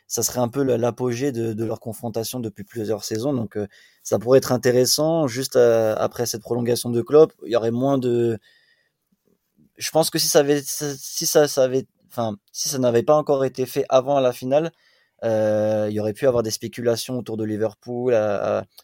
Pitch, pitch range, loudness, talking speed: 120 Hz, 115-135 Hz, -21 LUFS, 205 wpm